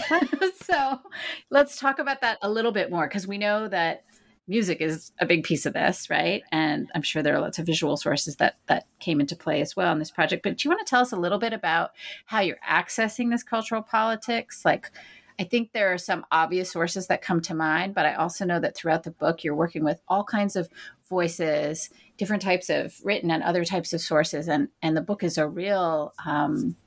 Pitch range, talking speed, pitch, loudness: 160-225 Hz, 225 wpm, 180 Hz, -25 LUFS